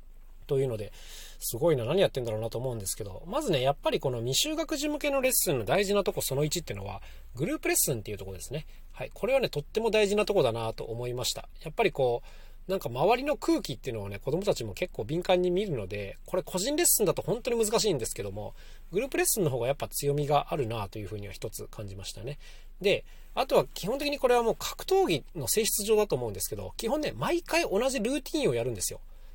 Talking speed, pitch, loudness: 495 characters per minute, 175 Hz, -29 LUFS